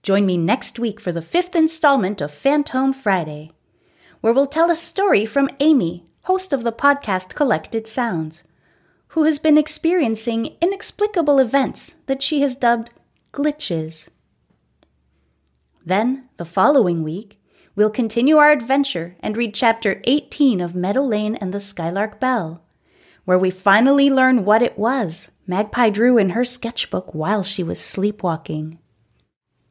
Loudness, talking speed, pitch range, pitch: -19 LUFS, 140 wpm, 185-275 Hz, 230 Hz